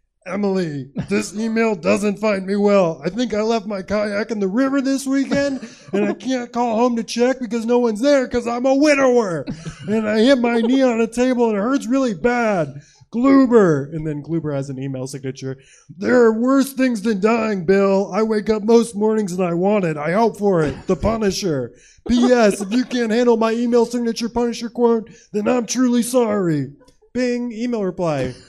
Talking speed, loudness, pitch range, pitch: 195 wpm, -18 LUFS, 190-245 Hz, 225 Hz